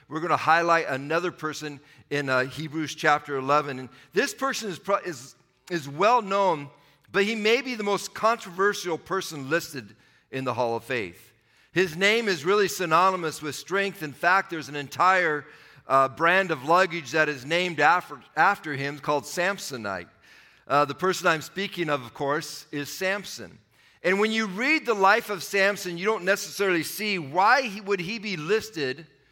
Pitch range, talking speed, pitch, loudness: 145-195 Hz, 175 wpm, 165 Hz, -25 LUFS